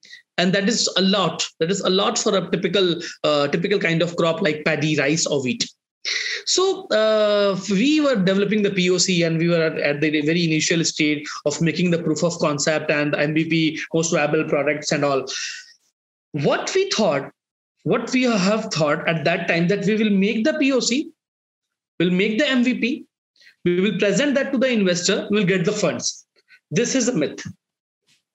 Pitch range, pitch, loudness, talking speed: 165-230 Hz, 190 Hz, -20 LUFS, 185 wpm